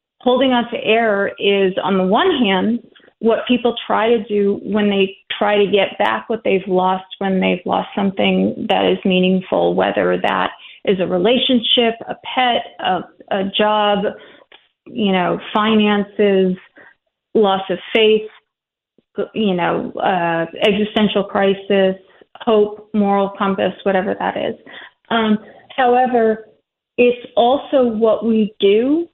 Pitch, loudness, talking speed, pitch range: 210 Hz, -17 LUFS, 130 wpm, 195-230 Hz